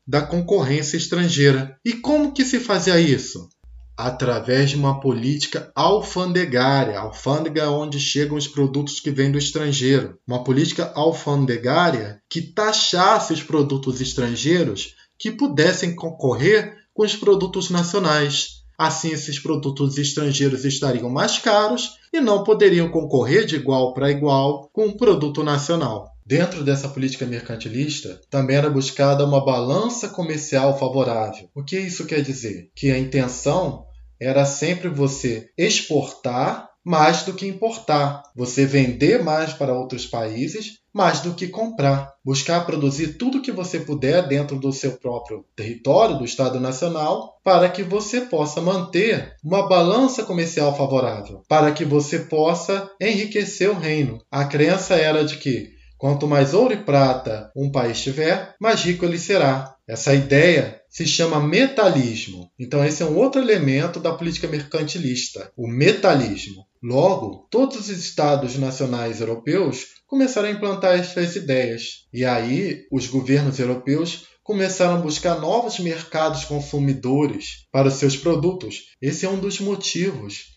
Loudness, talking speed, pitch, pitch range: -20 LUFS, 140 wpm, 145 Hz, 135-180 Hz